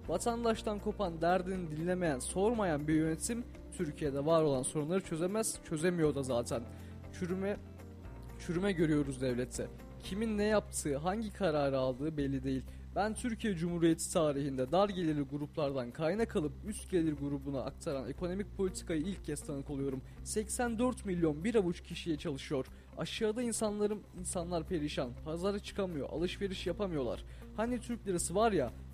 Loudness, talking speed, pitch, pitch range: -35 LUFS, 135 wpm, 170 Hz, 140-200 Hz